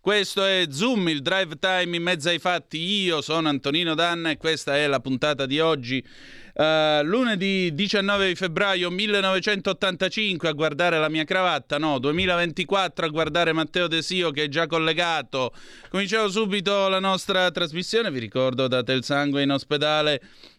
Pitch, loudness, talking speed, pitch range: 170 Hz, -23 LUFS, 155 wpm, 150-190 Hz